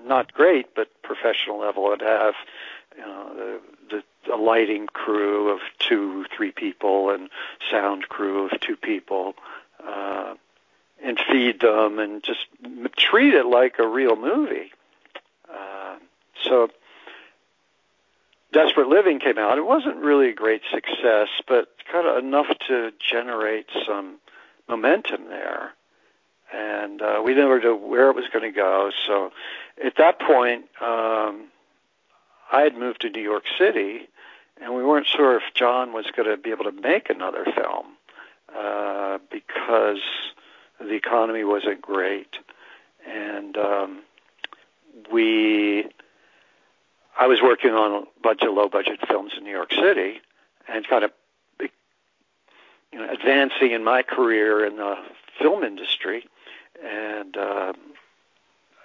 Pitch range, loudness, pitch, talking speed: 105-125 Hz, -22 LUFS, 110 Hz, 135 wpm